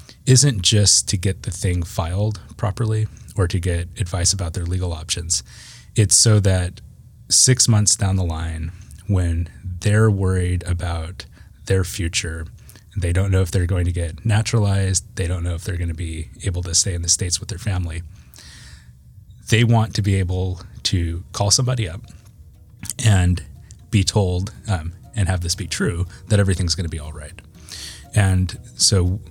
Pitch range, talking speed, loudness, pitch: 90-105 Hz, 170 wpm, -19 LUFS, 95 Hz